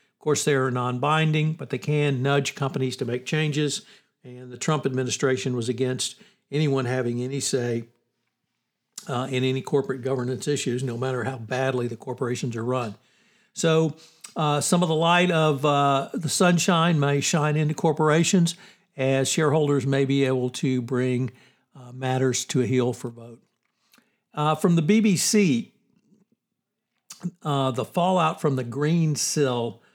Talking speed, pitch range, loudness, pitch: 155 wpm, 130-160 Hz, -24 LUFS, 140 Hz